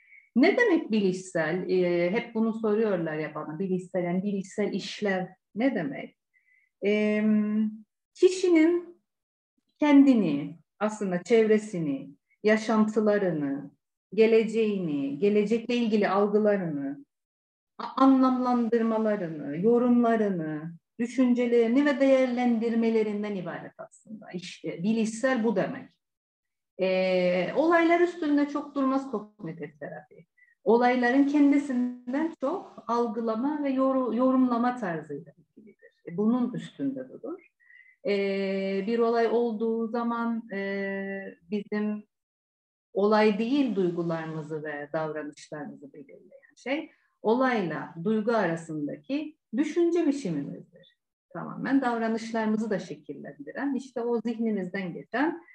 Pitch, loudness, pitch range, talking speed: 220 Hz, -26 LUFS, 185-260 Hz, 90 wpm